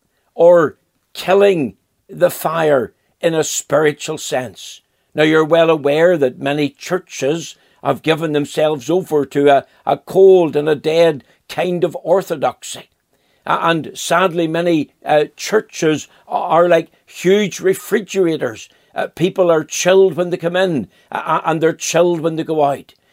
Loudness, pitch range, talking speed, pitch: -16 LUFS, 155-180 Hz, 140 wpm, 165 Hz